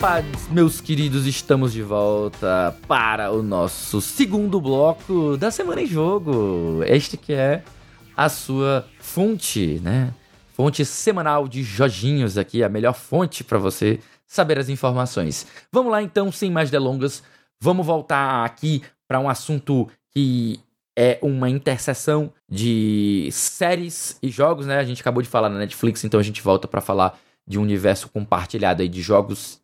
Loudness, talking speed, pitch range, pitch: -21 LUFS, 155 wpm, 110-150 Hz, 130 Hz